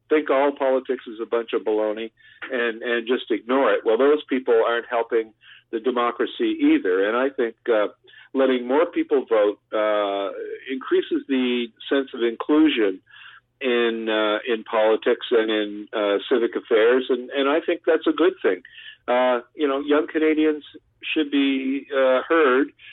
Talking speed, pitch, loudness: 160 wpm, 135 Hz, -22 LUFS